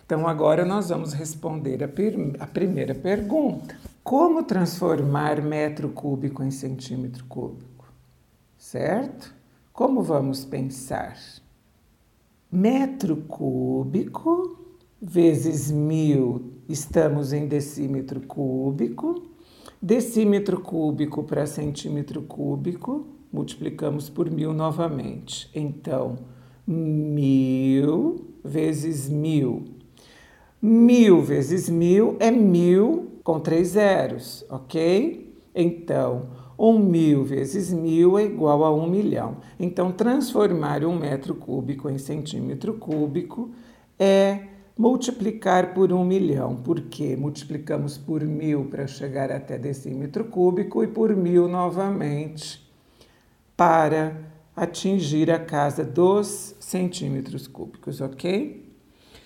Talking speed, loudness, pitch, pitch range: 95 wpm, -23 LUFS, 155 Hz, 145-195 Hz